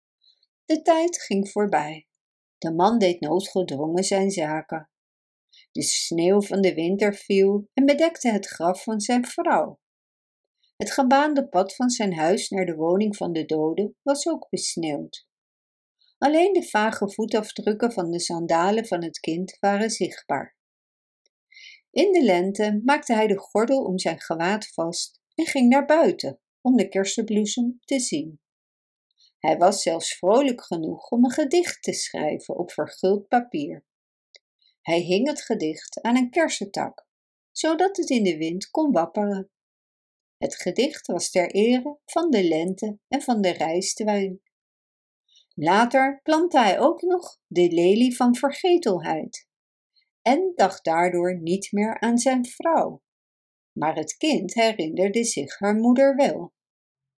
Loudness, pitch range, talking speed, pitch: -23 LUFS, 180-275 Hz, 140 wpm, 210 Hz